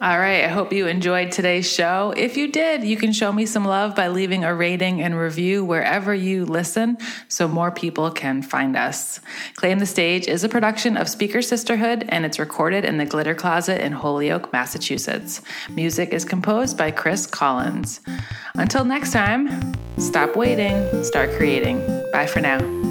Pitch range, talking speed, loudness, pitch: 165-215 Hz, 175 wpm, -21 LUFS, 185 Hz